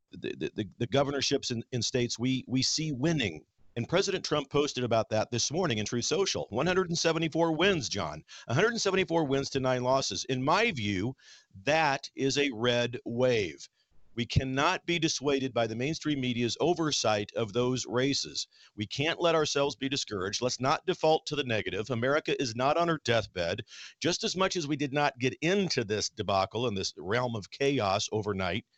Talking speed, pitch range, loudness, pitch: 175 wpm, 115-155 Hz, -29 LUFS, 130 Hz